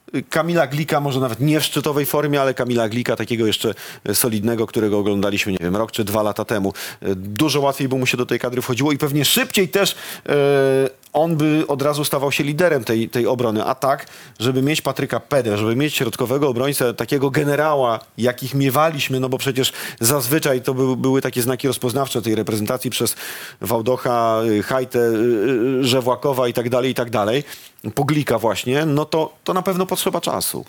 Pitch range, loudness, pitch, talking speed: 115-145 Hz, -19 LUFS, 130 Hz, 170 wpm